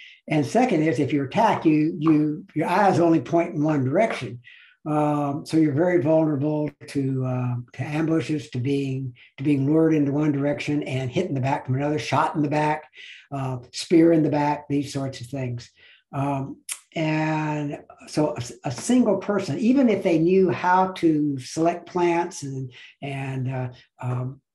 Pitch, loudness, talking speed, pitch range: 150 Hz, -23 LUFS, 175 wpm, 135-165 Hz